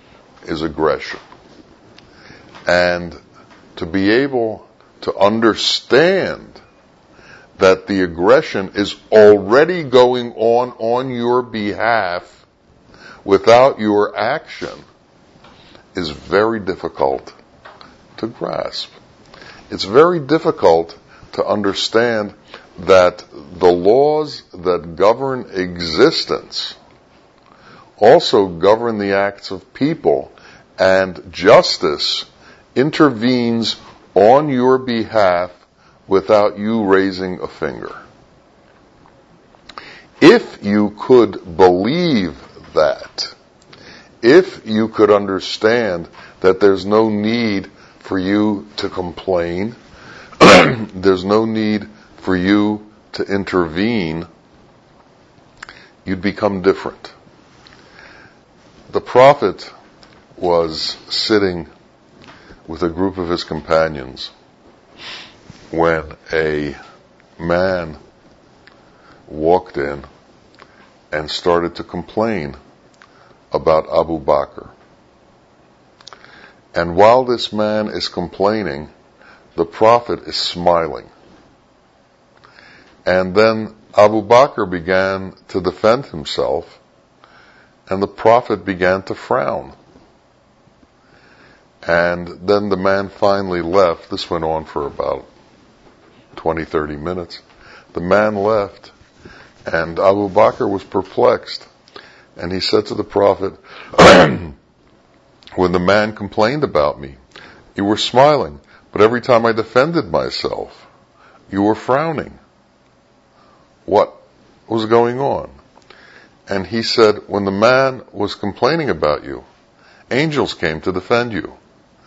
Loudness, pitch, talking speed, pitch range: -15 LUFS, 100 Hz, 95 wpm, 90-110 Hz